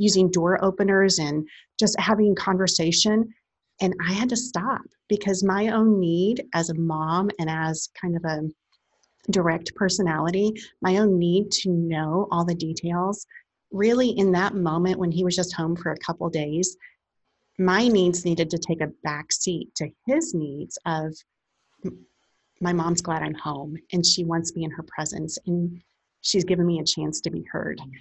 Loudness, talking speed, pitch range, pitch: -24 LUFS, 175 wpm, 165-195 Hz, 175 Hz